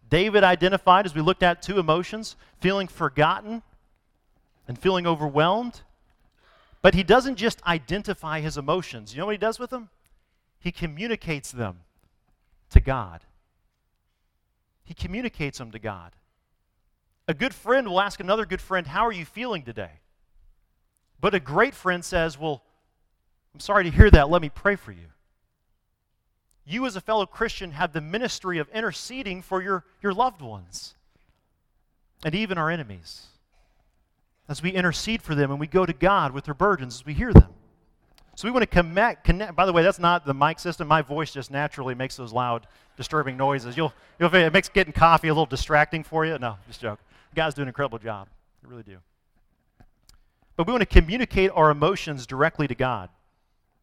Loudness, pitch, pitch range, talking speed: -23 LUFS, 160 Hz, 125-190 Hz, 175 wpm